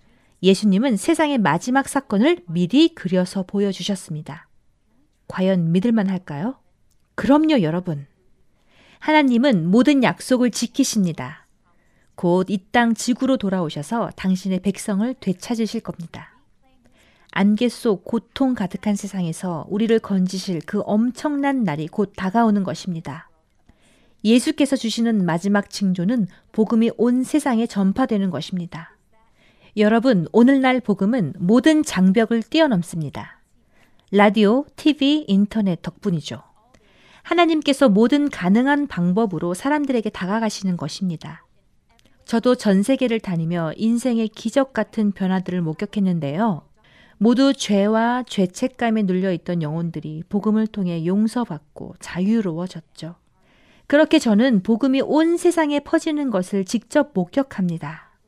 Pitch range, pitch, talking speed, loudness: 185-245 Hz, 210 Hz, 285 characters per minute, -20 LUFS